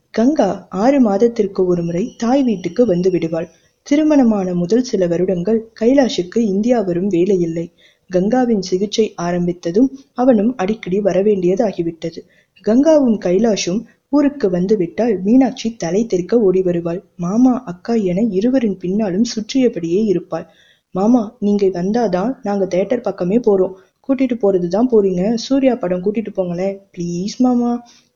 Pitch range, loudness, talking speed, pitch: 180-235 Hz, -16 LUFS, 120 wpm, 205 Hz